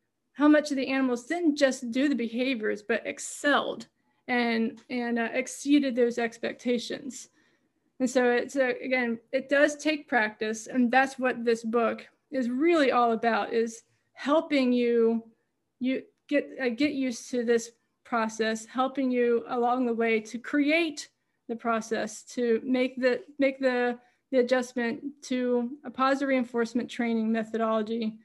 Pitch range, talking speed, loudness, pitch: 230-265 Hz, 145 wpm, -27 LUFS, 245 Hz